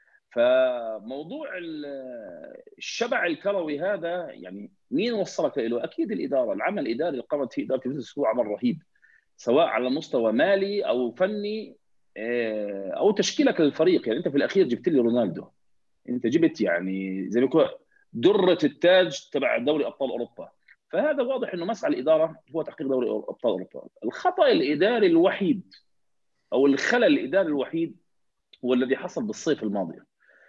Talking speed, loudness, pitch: 135 wpm, -25 LUFS, 195 Hz